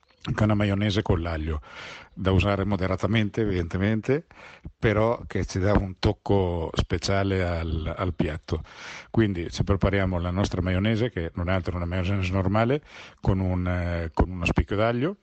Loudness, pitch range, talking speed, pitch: -26 LUFS, 90-105 Hz, 160 wpm, 95 Hz